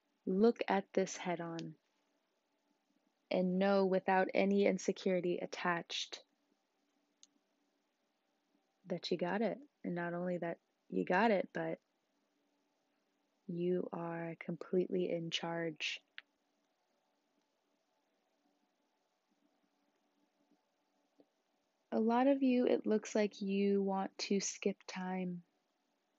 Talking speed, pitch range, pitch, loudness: 90 wpm, 170-200 Hz, 185 Hz, -36 LUFS